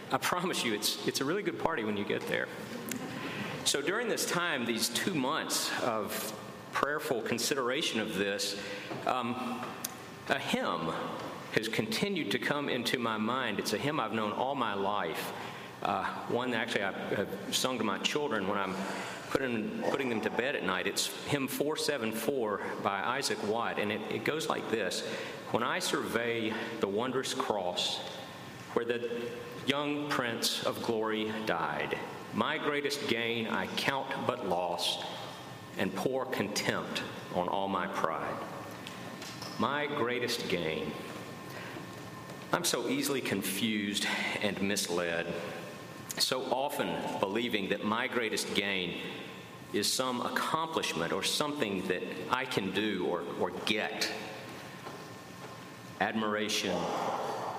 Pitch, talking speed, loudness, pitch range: 110 Hz, 135 wpm, -33 LUFS, 95-120 Hz